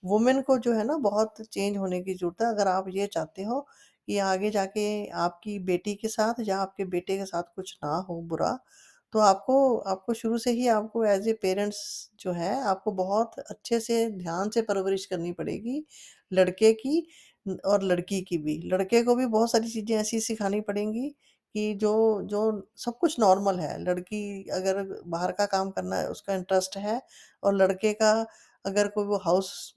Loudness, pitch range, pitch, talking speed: -27 LUFS, 190-225 Hz, 205 Hz, 185 wpm